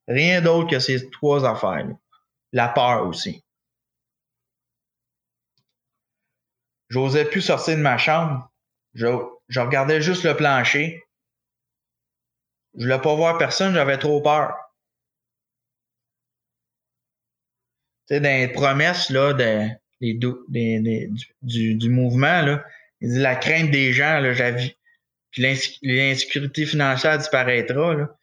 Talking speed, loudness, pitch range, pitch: 115 wpm, -20 LUFS, 120-150 Hz, 135 Hz